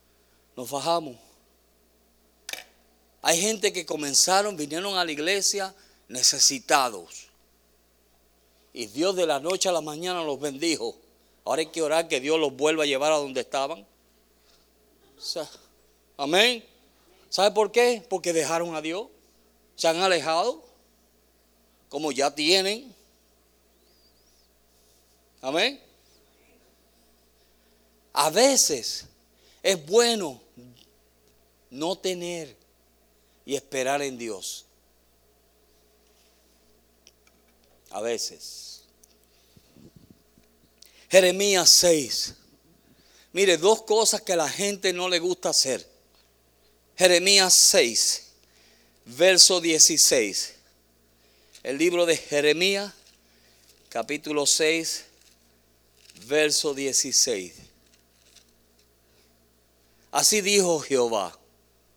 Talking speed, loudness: 90 wpm, -22 LUFS